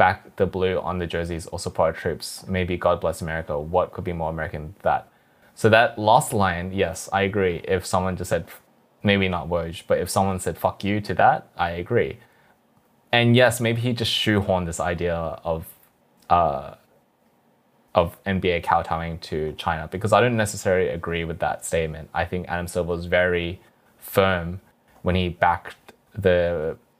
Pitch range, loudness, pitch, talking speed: 85-100 Hz, -23 LUFS, 90 Hz, 175 wpm